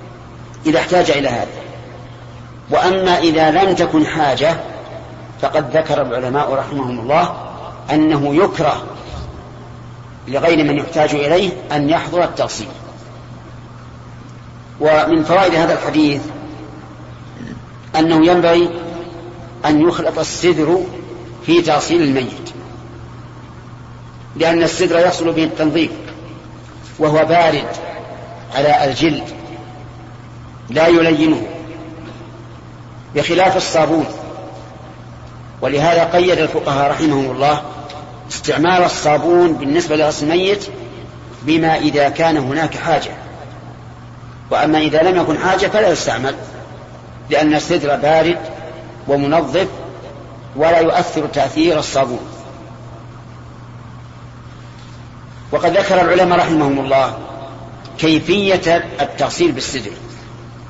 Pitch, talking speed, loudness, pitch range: 155 Hz, 85 wpm, -15 LUFS, 130-165 Hz